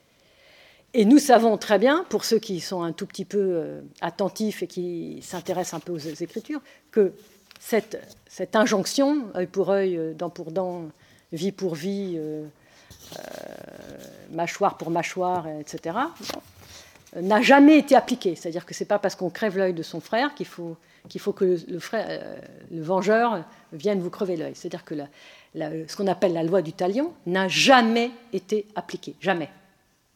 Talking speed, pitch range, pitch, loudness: 170 wpm, 170-210 Hz, 185 Hz, -24 LUFS